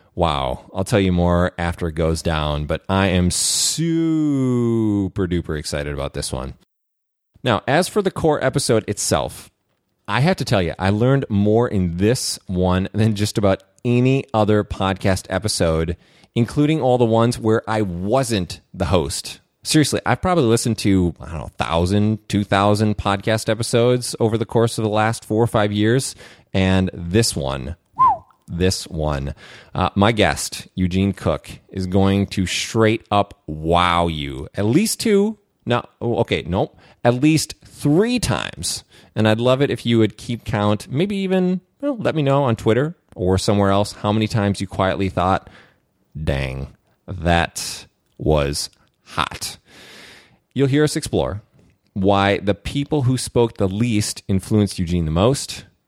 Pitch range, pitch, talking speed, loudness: 95-120 Hz, 105 Hz, 160 wpm, -19 LUFS